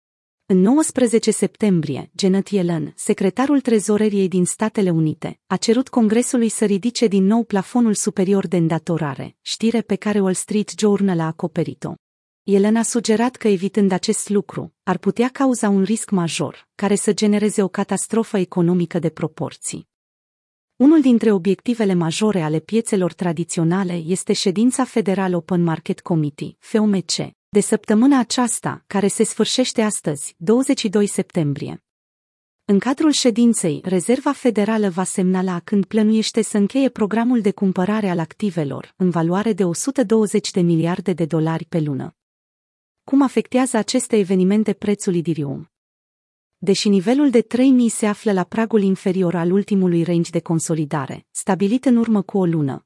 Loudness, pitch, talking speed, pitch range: -19 LUFS, 200 Hz, 140 wpm, 175-225 Hz